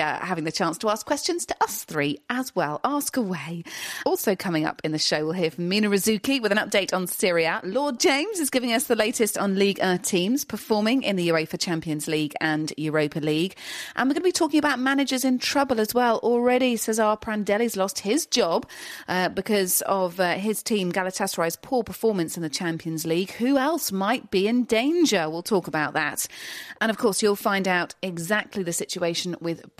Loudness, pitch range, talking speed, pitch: -24 LUFS, 170-240 Hz, 205 wpm, 200 Hz